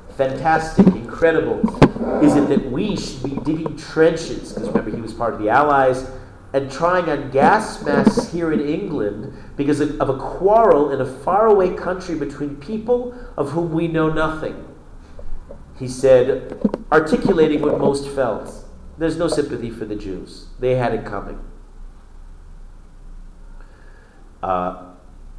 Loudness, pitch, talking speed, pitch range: -19 LUFS, 140 Hz, 140 wpm, 105-160 Hz